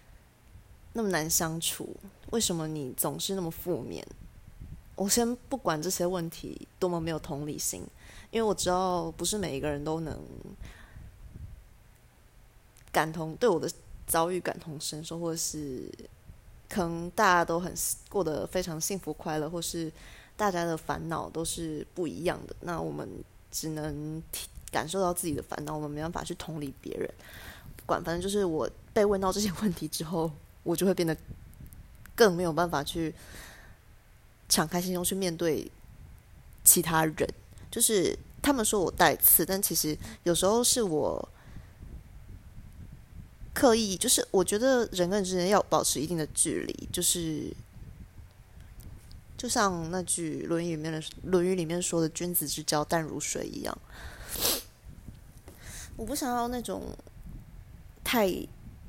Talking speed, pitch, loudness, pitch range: 215 characters per minute, 170 Hz, -29 LUFS, 155-190 Hz